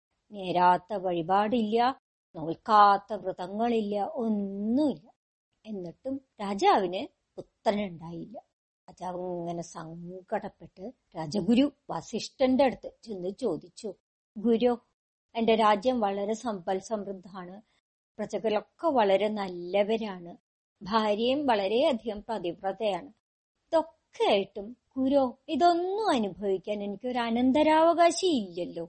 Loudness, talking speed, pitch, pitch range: -28 LUFS, 75 wpm, 210 Hz, 195-245 Hz